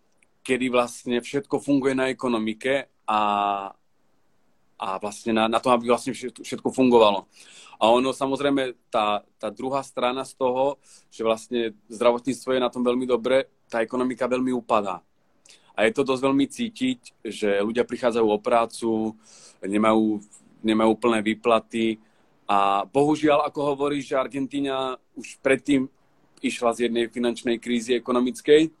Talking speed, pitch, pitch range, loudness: 135 wpm, 125 Hz, 115-135 Hz, -24 LUFS